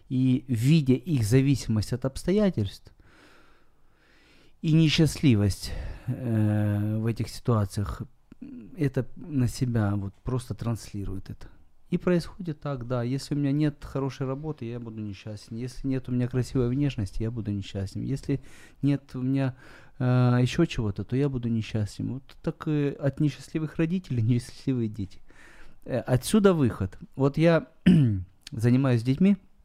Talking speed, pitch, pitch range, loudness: 135 wpm, 125 Hz, 110-140 Hz, -27 LUFS